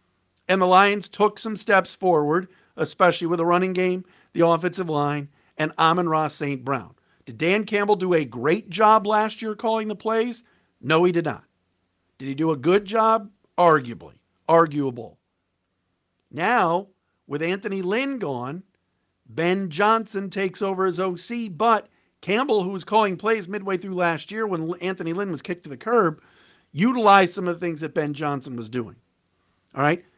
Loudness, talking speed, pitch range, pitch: -22 LUFS, 170 wpm, 145-200 Hz, 175 Hz